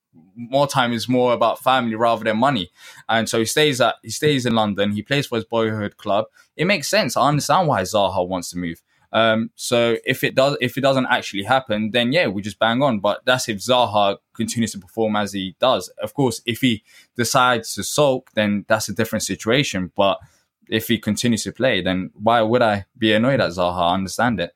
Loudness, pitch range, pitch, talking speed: -20 LUFS, 105-125 Hz, 115 Hz, 220 wpm